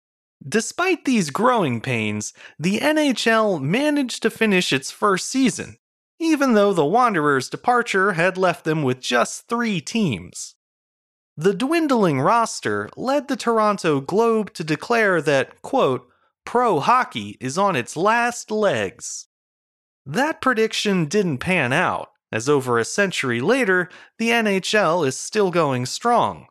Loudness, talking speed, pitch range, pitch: -20 LUFS, 130 wpm, 155-235 Hz, 205 Hz